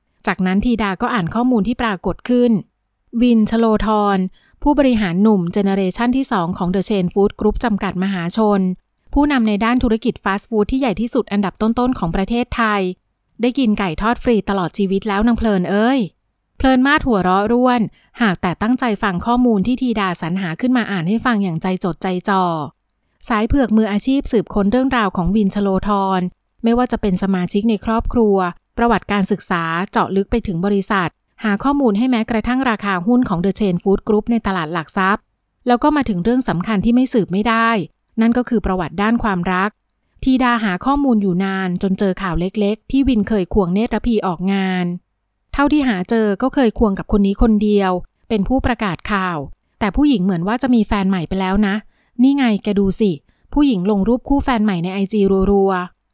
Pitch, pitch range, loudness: 210 Hz, 195-235 Hz, -17 LUFS